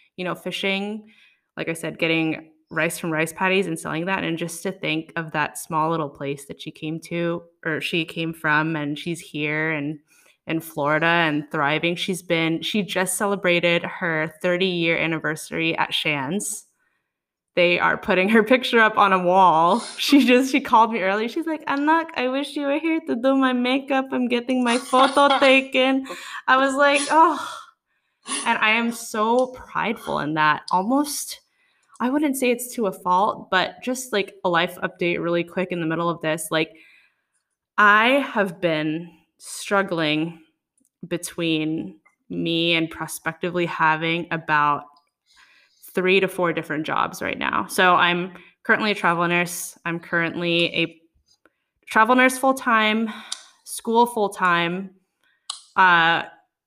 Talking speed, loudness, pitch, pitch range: 160 wpm, -21 LUFS, 180 Hz, 165-230 Hz